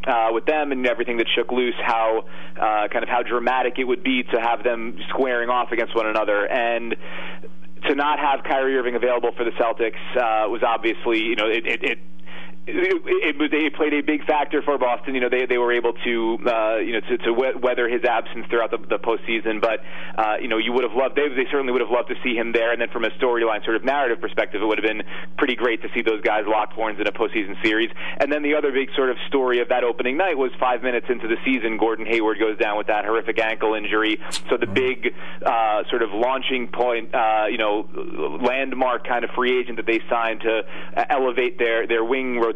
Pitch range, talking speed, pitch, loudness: 110-130 Hz, 235 wpm, 120 Hz, -22 LUFS